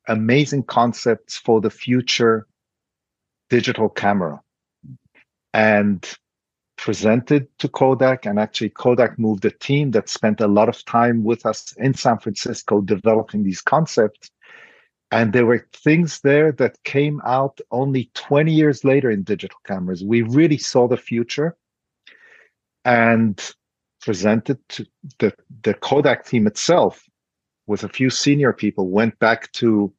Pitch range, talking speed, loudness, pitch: 110-135 Hz, 135 wpm, -19 LUFS, 120 Hz